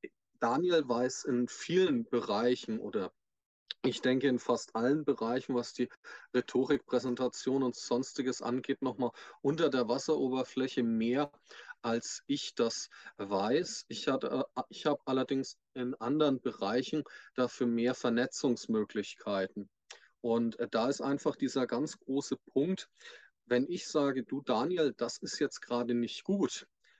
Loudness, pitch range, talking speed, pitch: -33 LUFS, 120-140 Hz, 130 wpm, 125 Hz